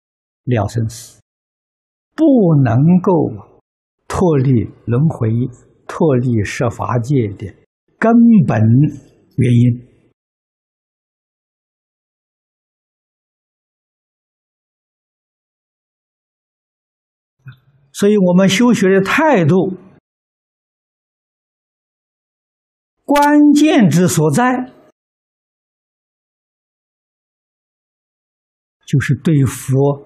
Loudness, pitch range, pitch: -13 LUFS, 120-185 Hz, 140 Hz